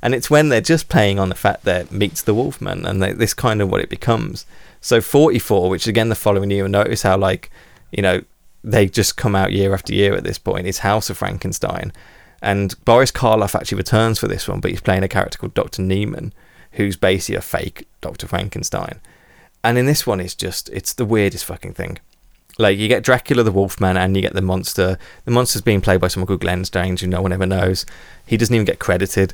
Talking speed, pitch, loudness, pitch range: 225 wpm, 100 Hz, -18 LUFS, 95-110 Hz